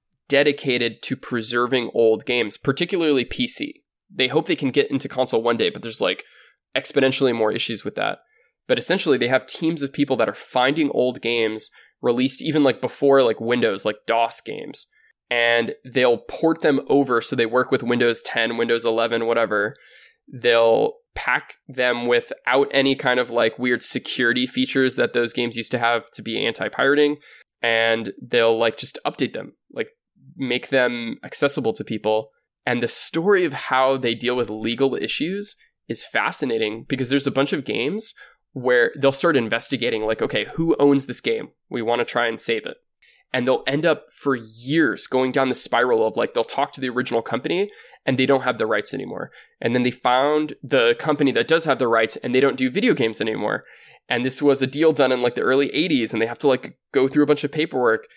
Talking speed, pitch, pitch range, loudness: 195 wpm, 130 Hz, 115-145 Hz, -21 LUFS